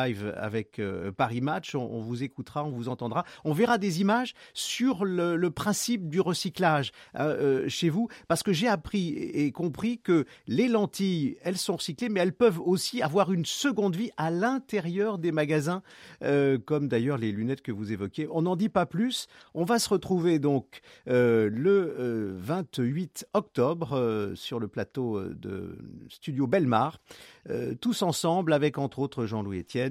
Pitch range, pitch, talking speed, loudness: 125-195 Hz, 165 Hz, 165 wpm, -28 LUFS